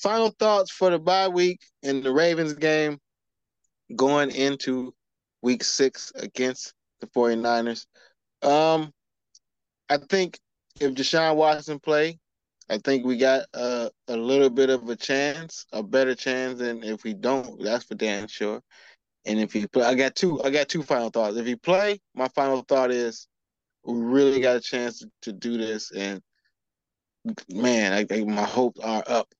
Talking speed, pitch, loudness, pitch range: 165 wpm, 130 Hz, -24 LUFS, 115-150 Hz